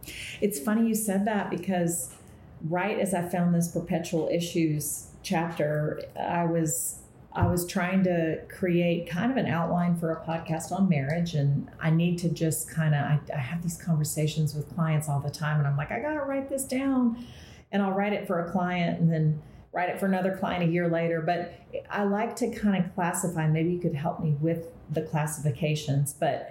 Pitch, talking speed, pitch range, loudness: 170 Hz, 200 wpm, 160-185 Hz, -28 LUFS